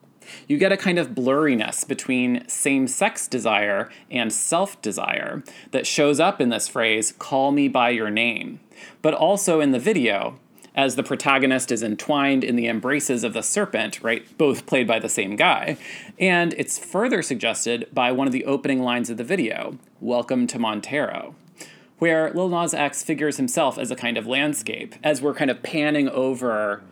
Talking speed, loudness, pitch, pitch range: 180 wpm, -22 LUFS, 140 Hz, 125-155 Hz